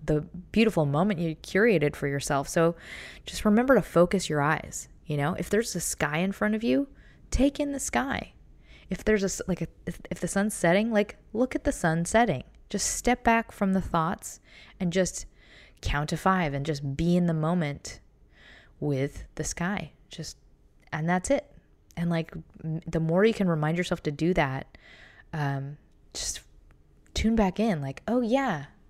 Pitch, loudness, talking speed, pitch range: 175 Hz, -27 LUFS, 180 wpm, 155-210 Hz